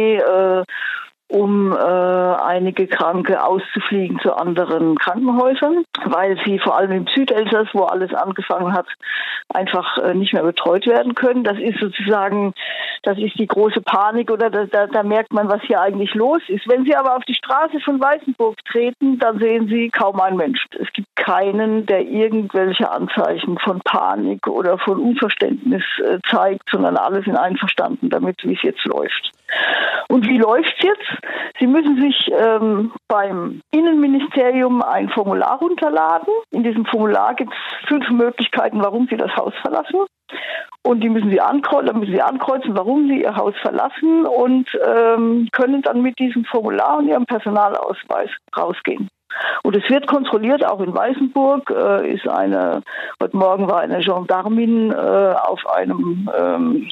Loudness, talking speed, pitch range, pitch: -17 LUFS, 160 wpm, 195-265 Hz, 225 Hz